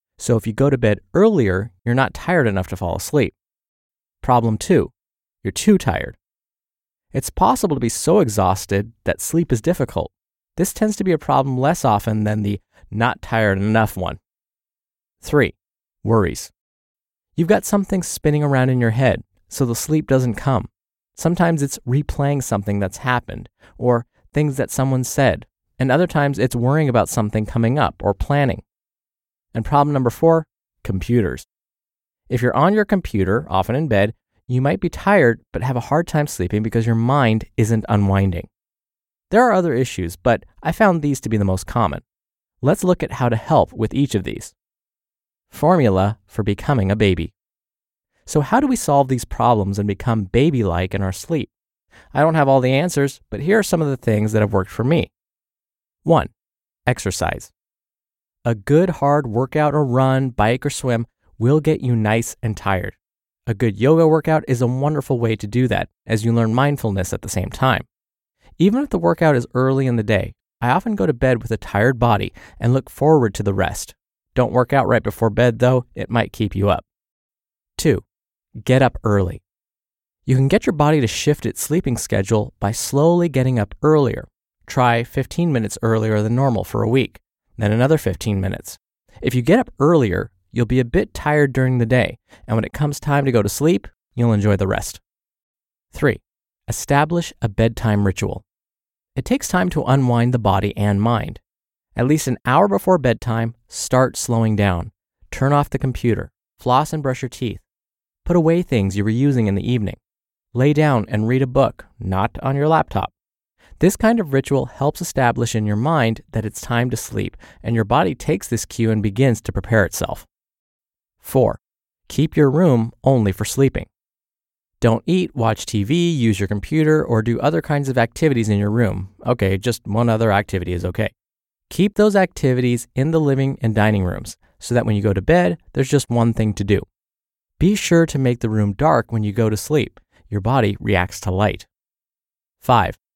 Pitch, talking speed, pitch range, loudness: 120 Hz, 185 wpm, 105-140 Hz, -19 LUFS